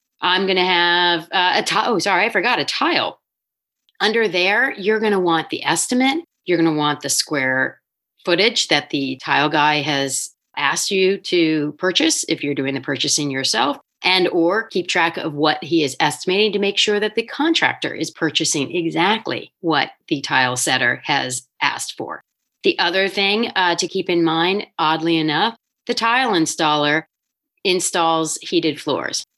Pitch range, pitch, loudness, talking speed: 150-200 Hz, 170 Hz, -18 LUFS, 170 wpm